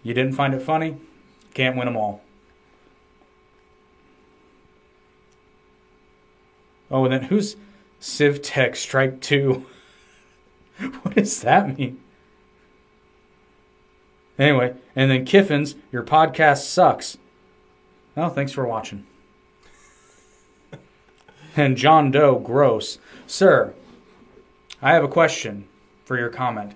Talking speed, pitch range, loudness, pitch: 95 wpm, 100-155 Hz, -20 LUFS, 130 Hz